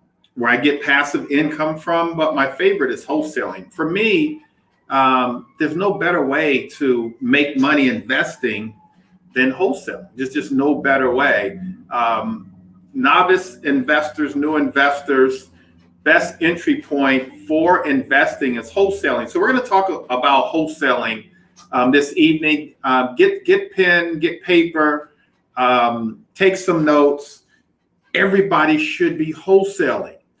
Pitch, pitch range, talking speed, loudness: 150 Hz, 130-190 Hz, 130 wpm, -17 LUFS